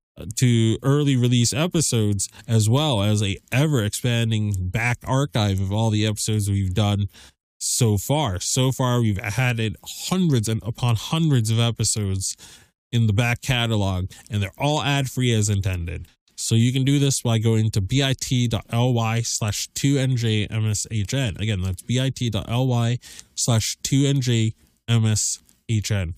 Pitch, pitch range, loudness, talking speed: 115 Hz, 105-125 Hz, -22 LUFS, 125 wpm